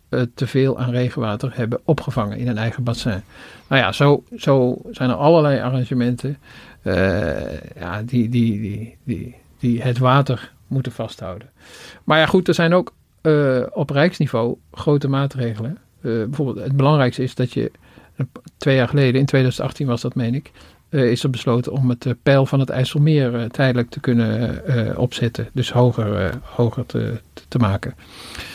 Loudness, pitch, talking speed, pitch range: -19 LUFS, 125 Hz, 165 wpm, 115-135 Hz